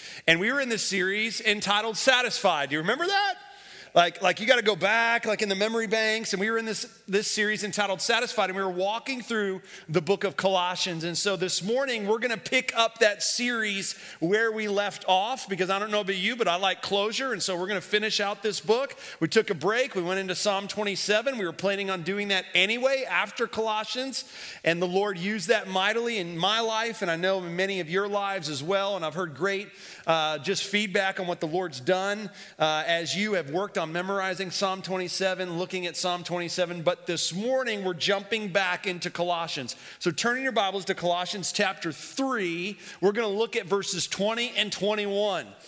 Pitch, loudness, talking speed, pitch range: 200 Hz, -26 LUFS, 215 wpm, 185-220 Hz